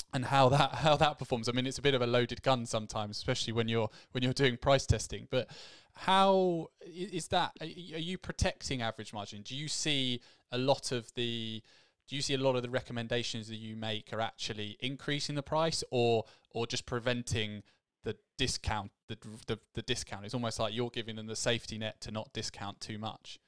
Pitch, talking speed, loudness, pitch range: 120 Hz, 205 wpm, -33 LUFS, 110-135 Hz